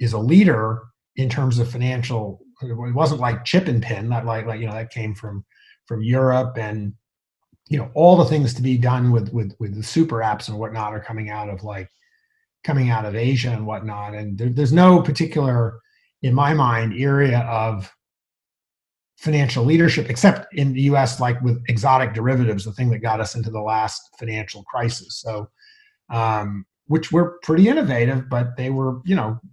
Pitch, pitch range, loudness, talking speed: 120 Hz, 110-140 Hz, -20 LUFS, 190 wpm